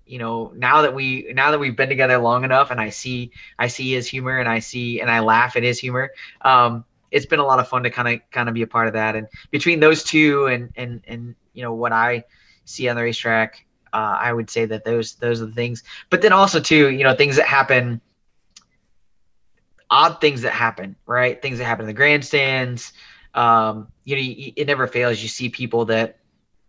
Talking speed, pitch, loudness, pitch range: 225 wpm, 120 Hz, -18 LUFS, 115-130 Hz